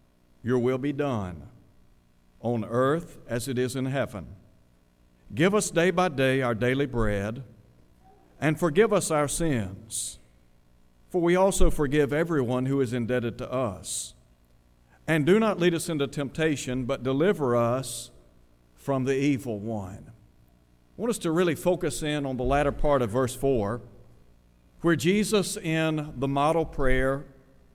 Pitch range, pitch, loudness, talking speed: 100-150 Hz, 130 Hz, -26 LUFS, 145 wpm